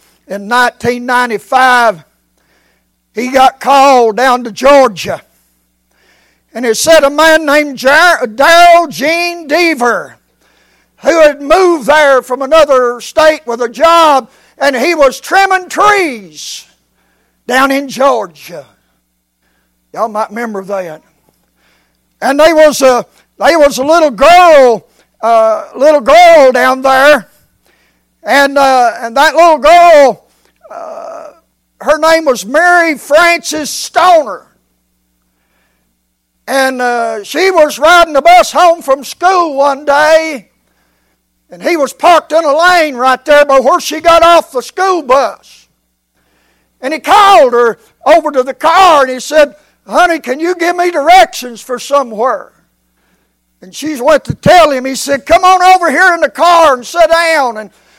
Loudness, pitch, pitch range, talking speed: -8 LUFS, 280 Hz, 240-325 Hz, 135 wpm